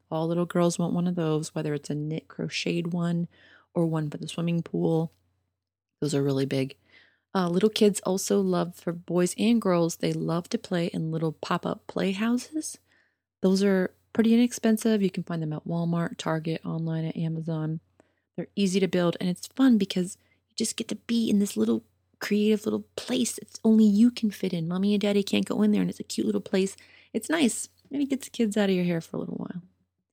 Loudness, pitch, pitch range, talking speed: -27 LUFS, 180 Hz, 160-210 Hz, 210 wpm